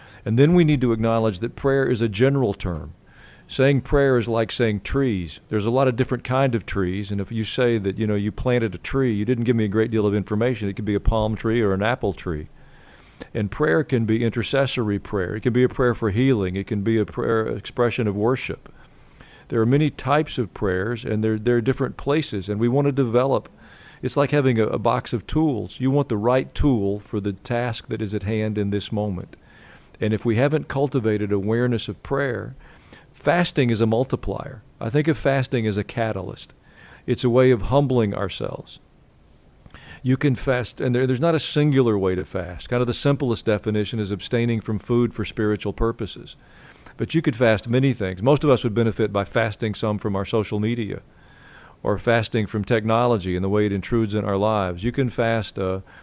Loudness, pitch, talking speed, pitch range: -22 LUFS, 115 Hz, 215 wpm, 105-130 Hz